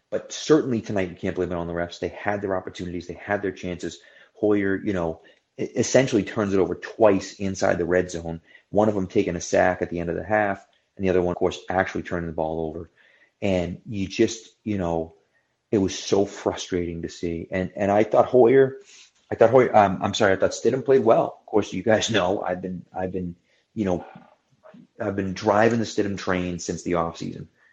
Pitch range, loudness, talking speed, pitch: 85-105 Hz, -23 LUFS, 215 wpm, 95 Hz